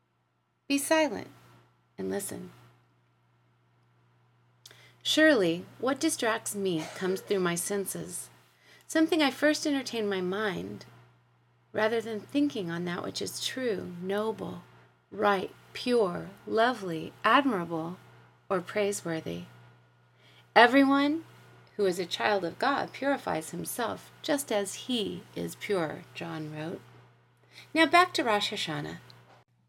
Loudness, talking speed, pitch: -29 LUFS, 110 wpm, 190 Hz